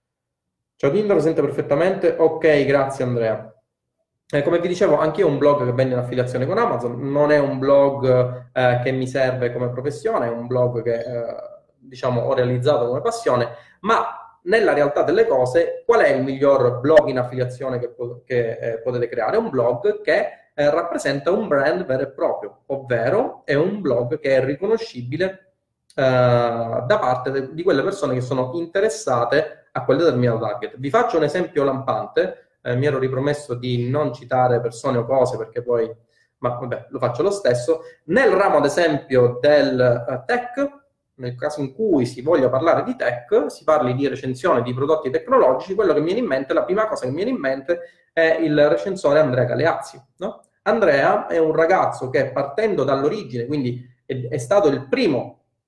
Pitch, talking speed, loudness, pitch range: 135 Hz, 185 wpm, -20 LUFS, 125-165 Hz